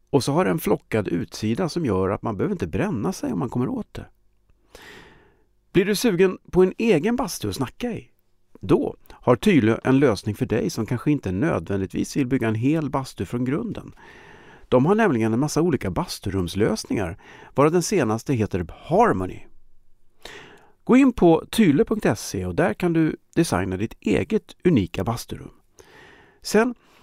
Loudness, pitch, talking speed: -22 LUFS, 140 Hz, 160 wpm